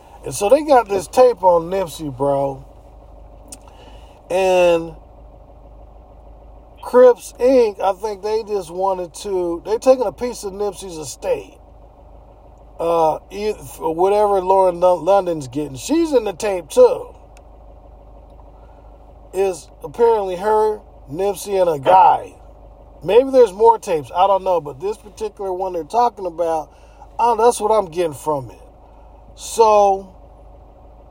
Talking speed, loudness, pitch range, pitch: 125 wpm, -17 LUFS, 175-235 Hz, 195 Hz